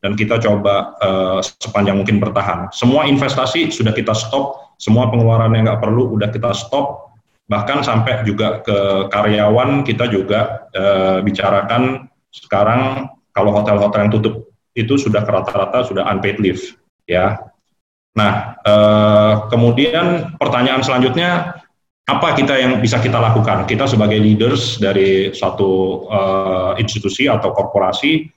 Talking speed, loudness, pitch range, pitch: 130 wpm, -15 LUFS, 100-125 Hz, 110 Hz